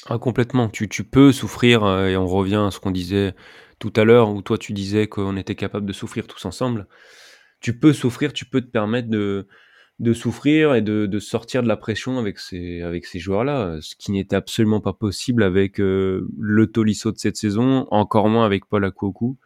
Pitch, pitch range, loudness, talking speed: 105 Hz, 100-120 Hz, -20 LUFS, 205 wpm